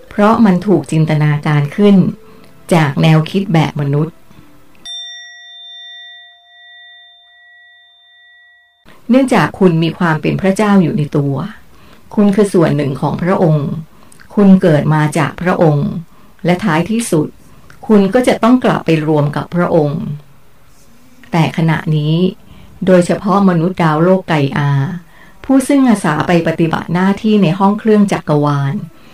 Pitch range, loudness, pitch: 160-210 Hz, -13 LUFS, 180 Hz